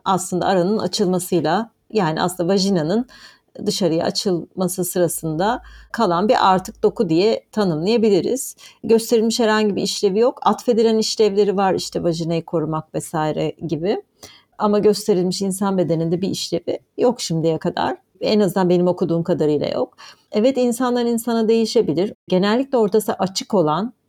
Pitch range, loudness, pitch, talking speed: 175-225 Hz, -19 LUFS, 195 Hz, 125 wpm